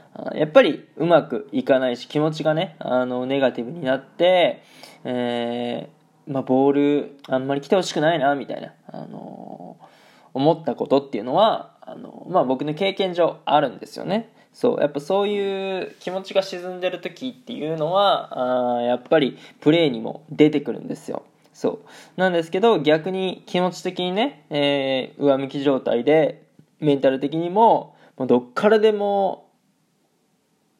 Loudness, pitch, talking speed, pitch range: -21 LUFS, 155 Hz, 315 characters per minute, 135-190 Hz